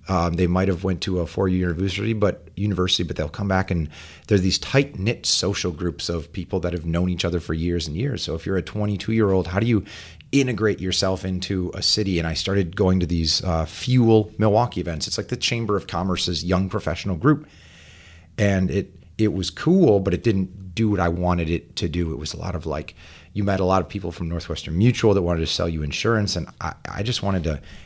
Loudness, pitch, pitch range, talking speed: -22 LUFS, 95 Hz, 85-105 Hz, 235 wpm